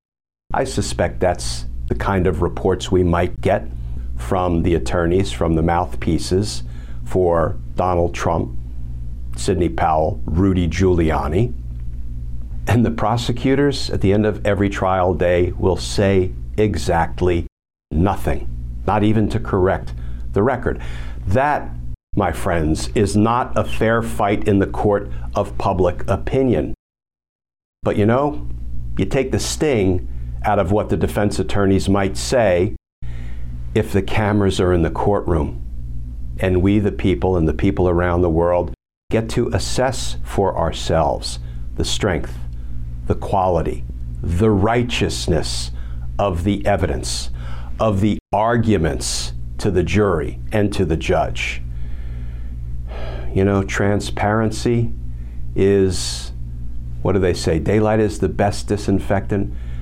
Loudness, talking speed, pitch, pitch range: -19 LUFS, 125 wpm, 85 Hz, 60-100 Hz